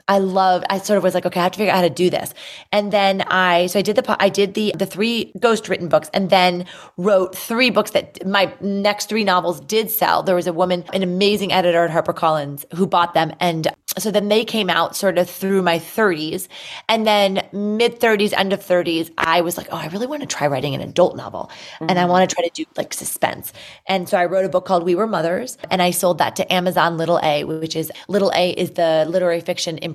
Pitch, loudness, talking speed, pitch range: 185 Hz, -18 LUFS, 245 wpm, 175-200 Hz